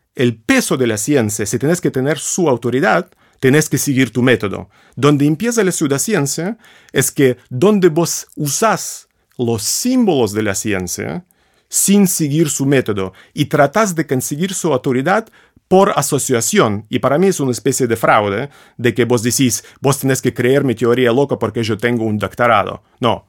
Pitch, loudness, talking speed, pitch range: 135 Hz, -15 LUFS, 175 wpm, 120-160 Hz